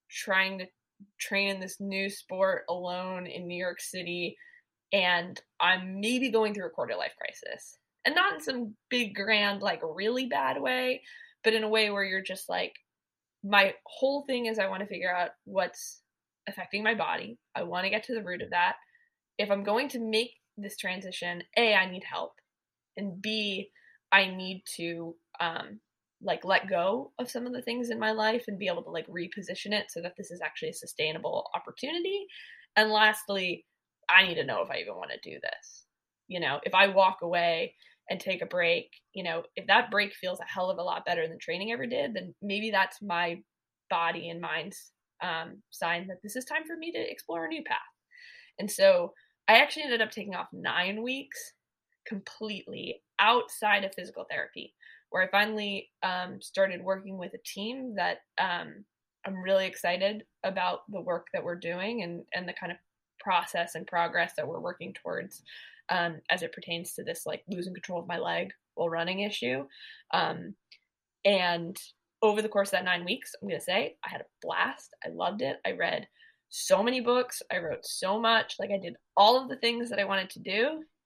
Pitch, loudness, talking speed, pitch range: 200 Hz, -30 LUFS, 195 wpm, 180-235 Hz